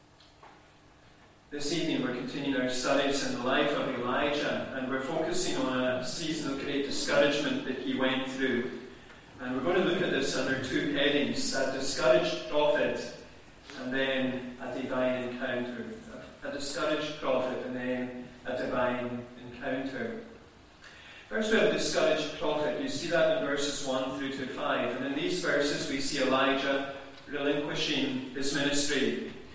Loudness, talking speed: -30 LUFS, 150 wpm